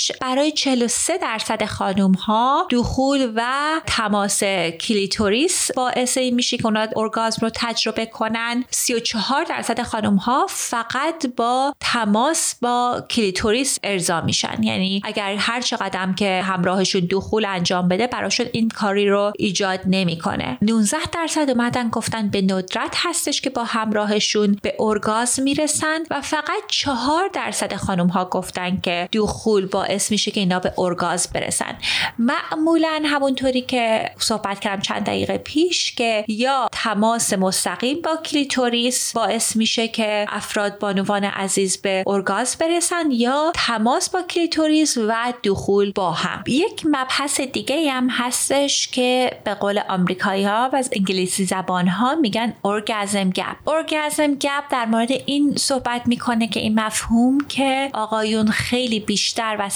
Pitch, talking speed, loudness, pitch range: 230 Hz, 140 wpm, -20 LUFS, 200-270 Hz